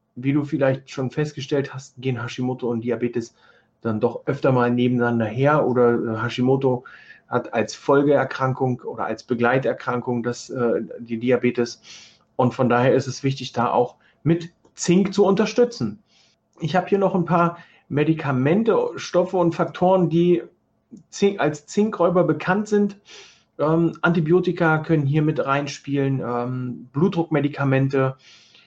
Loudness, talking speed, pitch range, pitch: -21 LUFS, 135 wpm, 125-170 Hz, 140 Hz